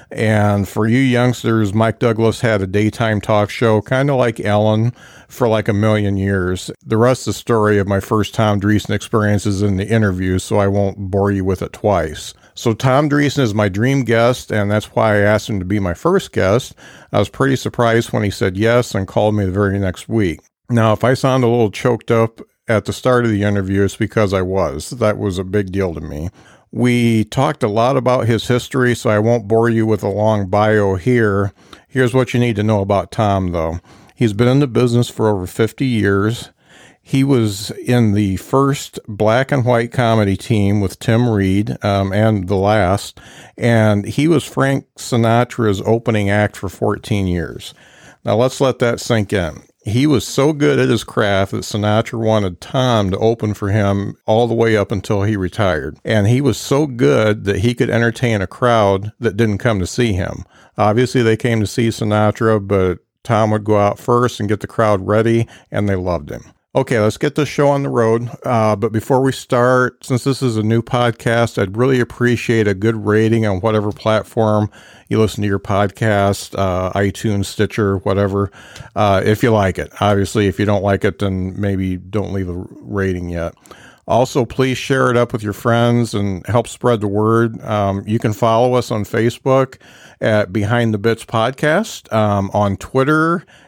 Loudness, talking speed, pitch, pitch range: -16 LUFS, 200 wpm, 110 Hz, 100-120 Hz